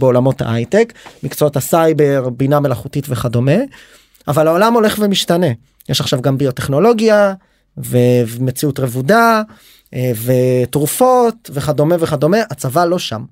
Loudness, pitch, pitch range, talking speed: -14 LUFS, 150 Hz, 130-190 Hz, 105 wpm